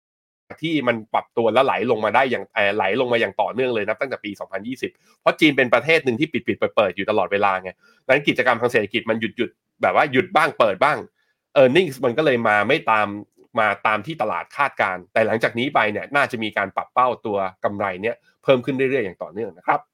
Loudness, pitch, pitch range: -20 LUFS, 115 Hz, 100-145 Hz